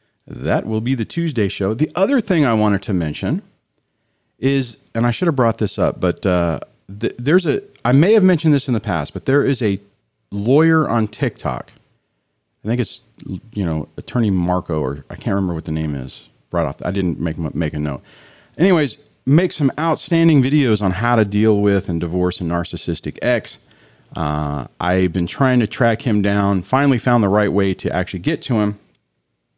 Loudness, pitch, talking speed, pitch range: -18 LUFS, 105 Hz, 195 wpm, 90-135 Hz